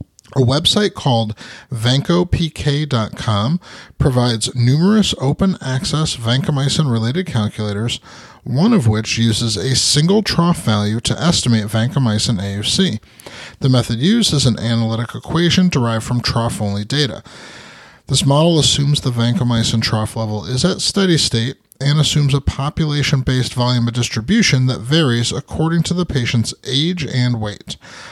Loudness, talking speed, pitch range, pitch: -16 LUFS, 130 wpm, 115-150 Hz, 130 Hz